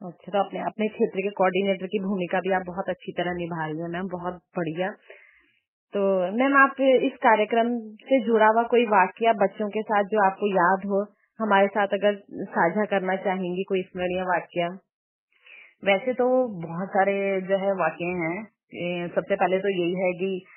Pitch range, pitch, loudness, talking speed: 180-210 Hz, 195 Hz, -24 LUFS, 160 wpm